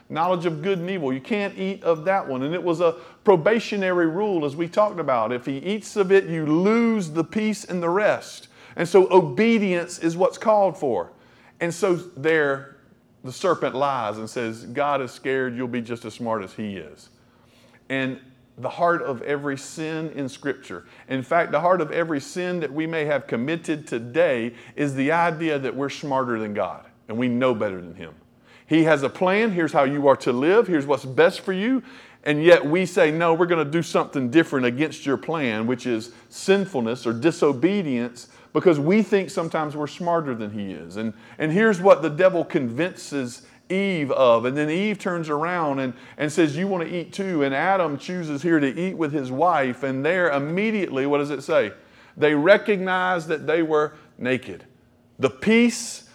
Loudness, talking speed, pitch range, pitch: -22 LUFS, 195 wpm, 130-180 Hz, 160 Hz